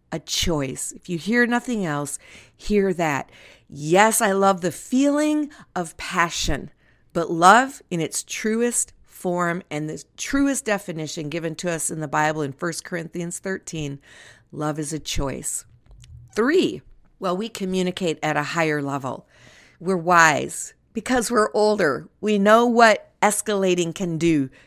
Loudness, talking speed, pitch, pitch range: -22 LUFS, 145 wpm, 180 Hz, 160-215 Hz